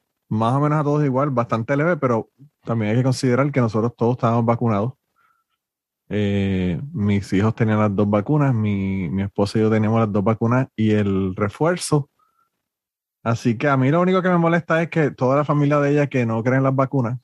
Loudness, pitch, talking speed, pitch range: -20 LUFS, 125 Hz, 200 wpm, 110-145 Hz